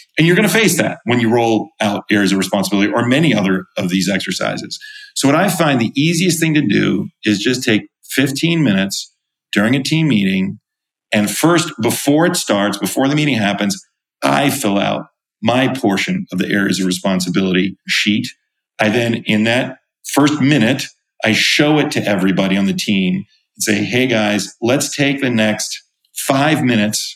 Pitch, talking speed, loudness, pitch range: 120 Hz, 180 wpm, -15 LUFS, 100-155 Hz